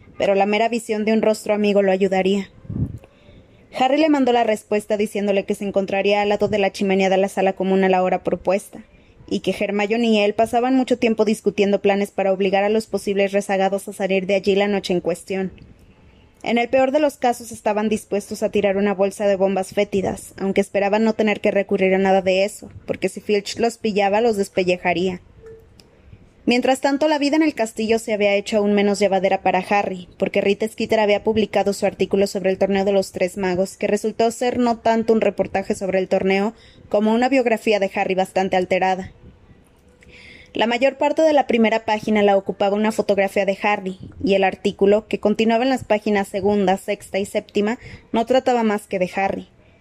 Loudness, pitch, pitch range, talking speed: -19 LUFS, 205 Hz, 195-220 Hz, 200 wpm